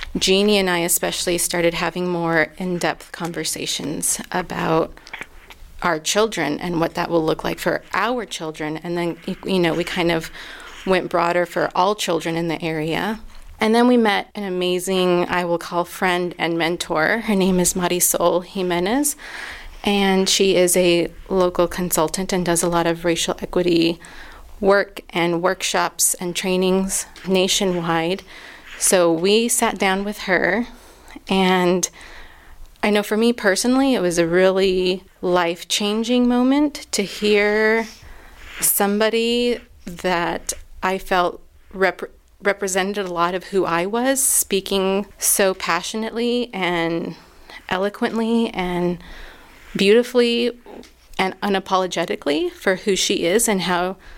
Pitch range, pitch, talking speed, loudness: 175-205 Hz, 185 Hz, 135 wpm, -19 LUFS